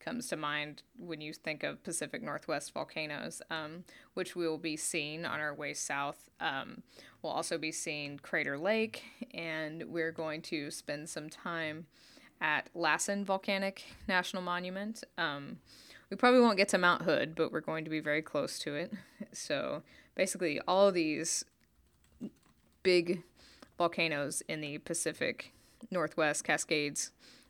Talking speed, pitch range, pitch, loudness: 150 wpm, 155-185 Hz, 165 Hz, -34 LUFS